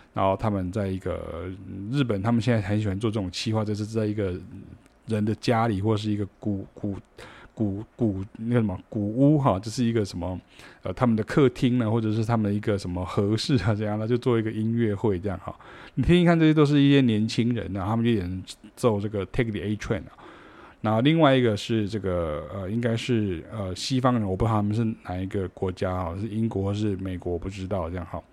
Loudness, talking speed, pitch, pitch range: -25 LUFS, 345 characters per minute, 105 Hz, 95-115 Hz